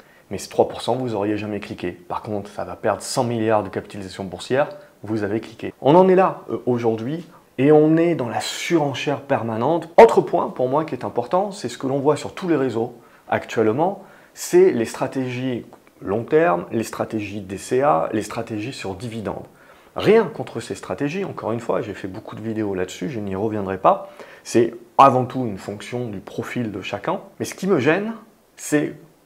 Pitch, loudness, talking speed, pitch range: 120 Hz, -21 LUFS, 190 wpm, 105-150 Hz